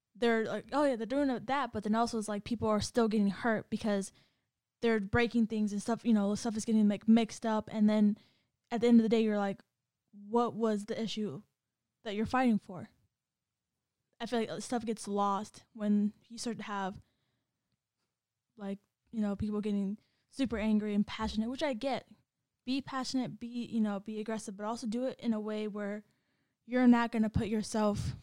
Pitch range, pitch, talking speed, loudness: 210-235 Hz, 220 Hz, 200 wpm, -33 LUFS